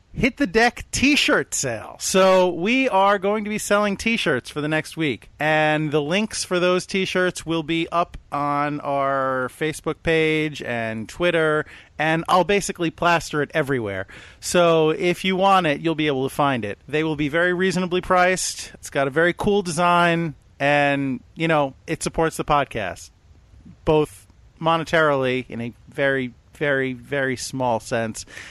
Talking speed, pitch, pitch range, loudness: 170 wpm, 155 Hz, 135-180 Hz, -21 LUFS